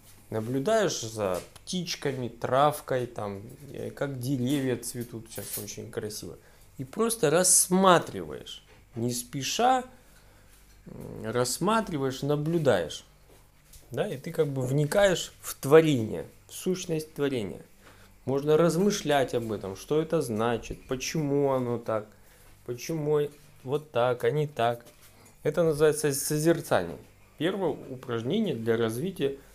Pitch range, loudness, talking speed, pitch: 115-155 Hz, -27 LUFS, 105 wpm, 135 Hz